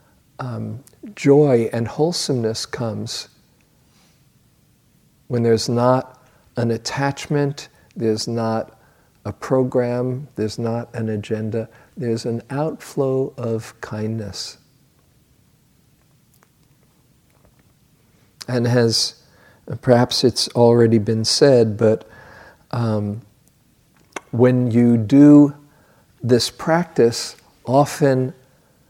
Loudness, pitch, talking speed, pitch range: -19 LUFS, 120 Hz, 80 wpm, 115-135 Hz